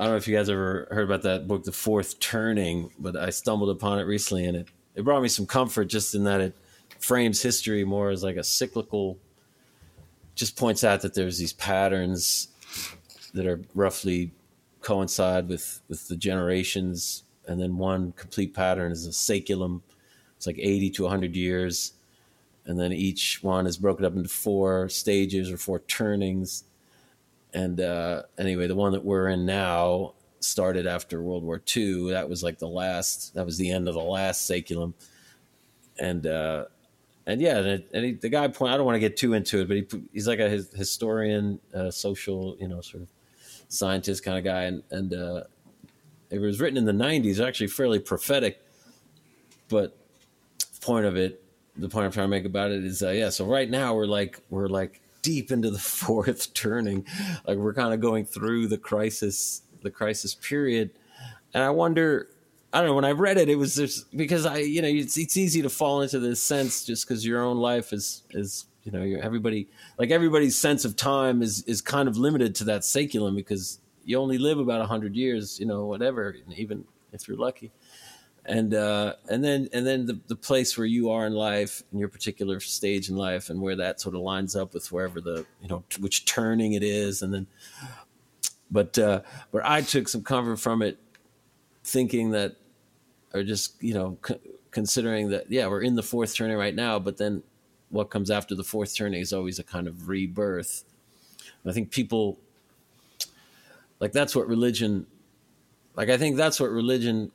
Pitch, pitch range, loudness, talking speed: 100 Hz, 95-115 Hz, -27 LUFS, 195 wpm